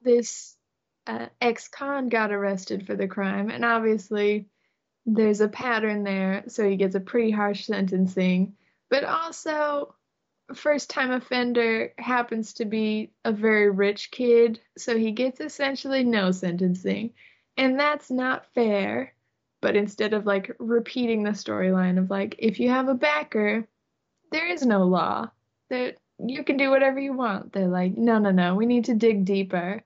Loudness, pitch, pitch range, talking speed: -25 LUFS, 225 Hz, 200-250 Hz, 160 wpm